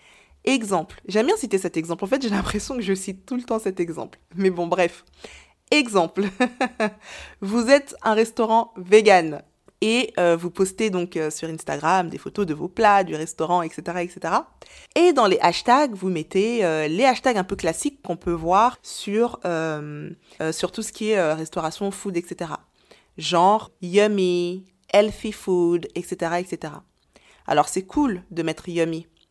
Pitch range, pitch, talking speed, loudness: 170-215 Hz, 185 Hz, 170 wpm, -22 LUFS